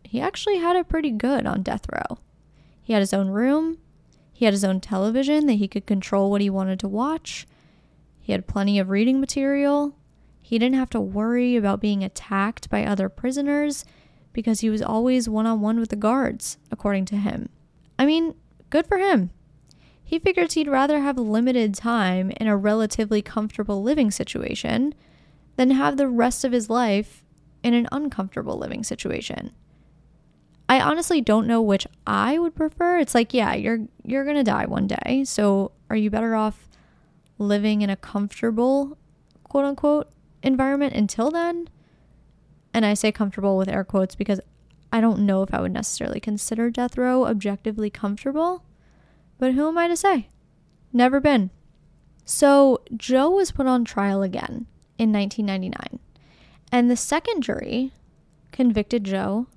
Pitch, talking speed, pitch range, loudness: 230 Hz, 165 wpm, 205-270 Hz, -22 LUFS